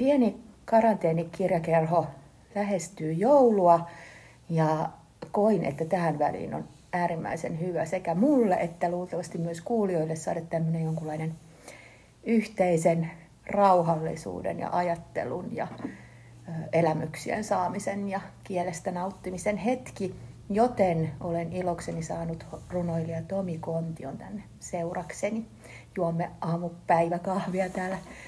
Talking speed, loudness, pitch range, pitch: 95 wpm, -28 LUFS, 165-195 Hz, 175 Hz